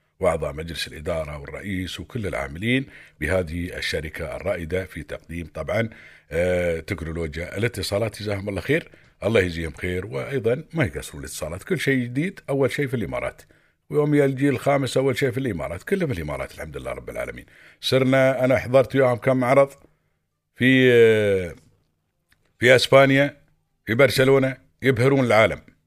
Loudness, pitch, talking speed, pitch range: -22 LUFS, 125 Hz, 135 wpm, 90-135 Hz